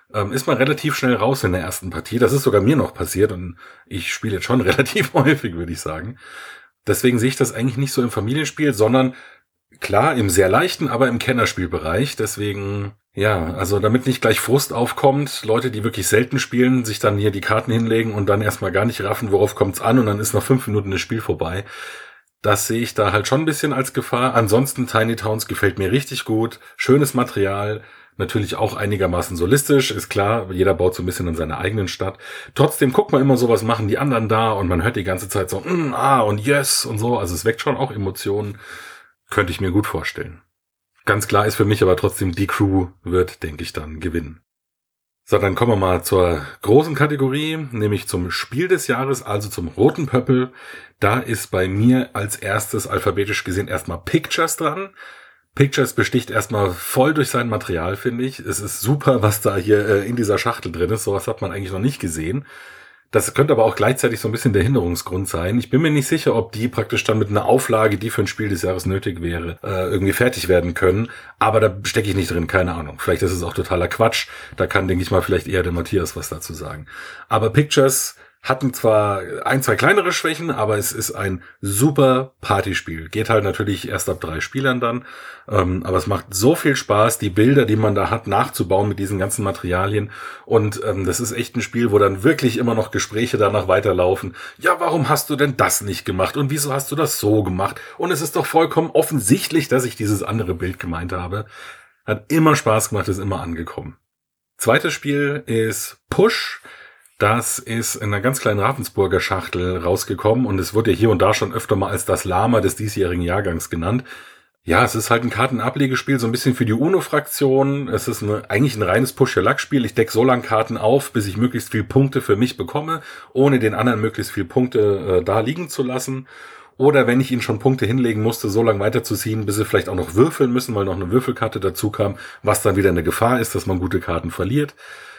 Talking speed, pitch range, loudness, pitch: 210 wpm, 100-130 Hz, -19 LUFS, 110 Hz